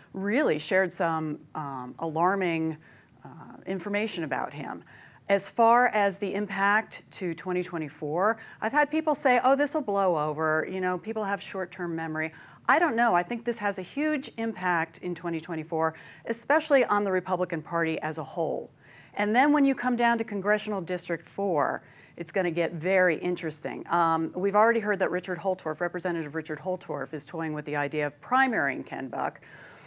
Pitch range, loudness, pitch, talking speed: 160-210 Hz, -27 LUFS, 180 Hz, 175 wpm